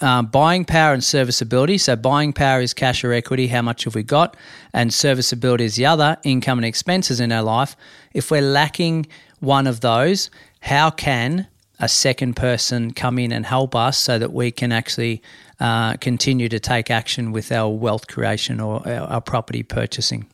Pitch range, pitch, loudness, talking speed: 115-140 Hz, 125 Hz, -19 LUFS, 185 wpm